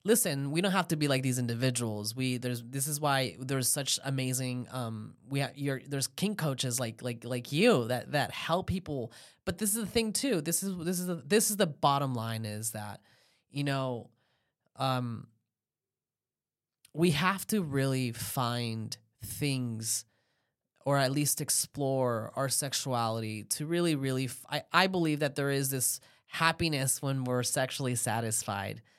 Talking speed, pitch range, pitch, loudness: 170 wpm, 120-150 Hz, 135 Hz, -31 LUFS